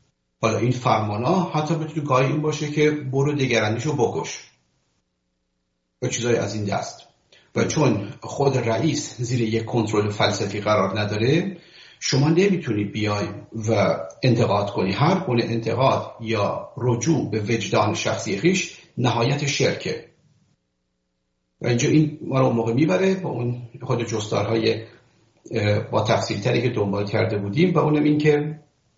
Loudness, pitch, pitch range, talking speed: -22 LUFS, 115 Hz, 105-145 Hz, 140 wpm